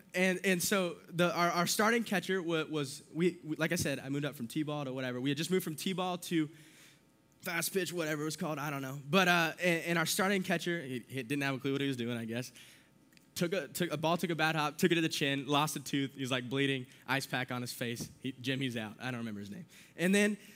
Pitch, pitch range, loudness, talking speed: 155 Hz, 135-175 Hz, -33 LUFS, 275 wpm